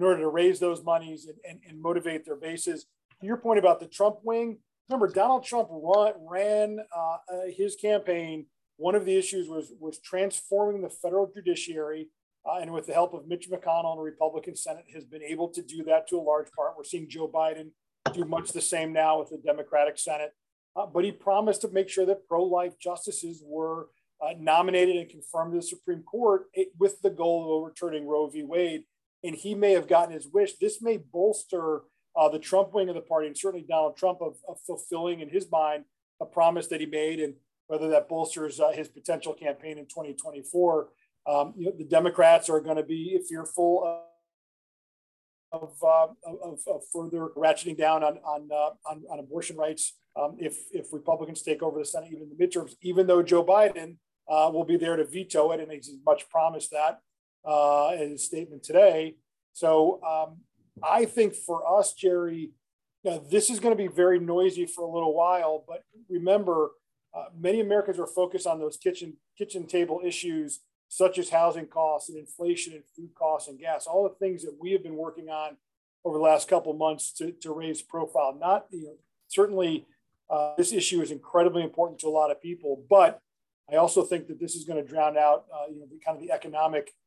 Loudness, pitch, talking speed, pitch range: -27 LUFS, 165 Hz, 200 wpm, 155-185 Hz